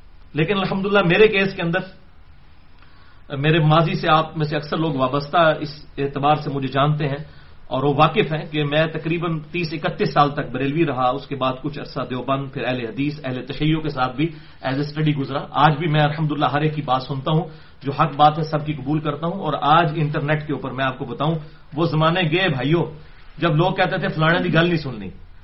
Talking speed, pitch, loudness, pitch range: 220 wpm, 150 Hz, -20 LUFS, 140-165 Hz